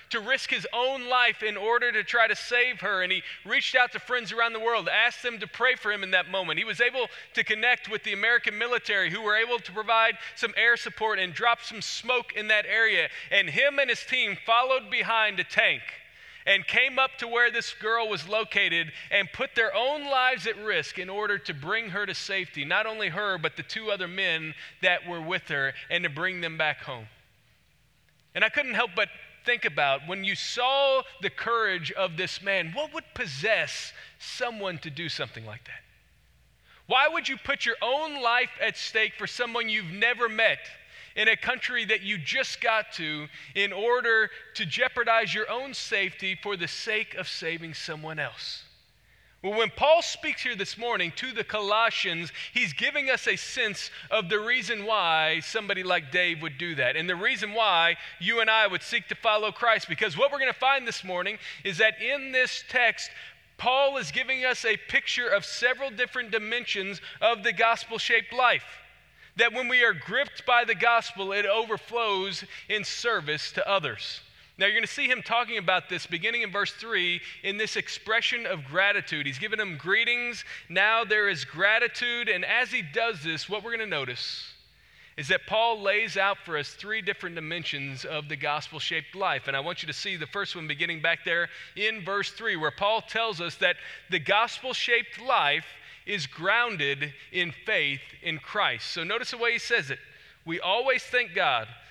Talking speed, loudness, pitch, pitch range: 195 wpm, -26 LUFS, 215 Hz, 180-235 Hz